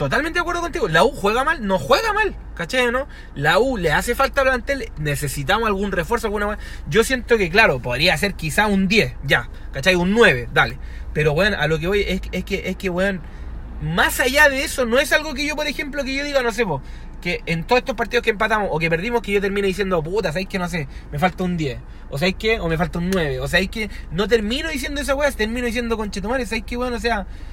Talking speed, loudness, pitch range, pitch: 245 wpm, -20 LUFS, 175-250 Hz, 210 Hz